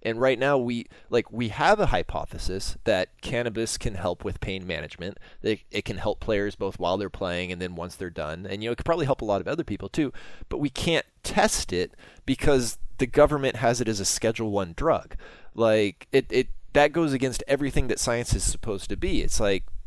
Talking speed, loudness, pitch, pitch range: 220 wpm, -26 LUFS, 115 Hz, 95-130 Hz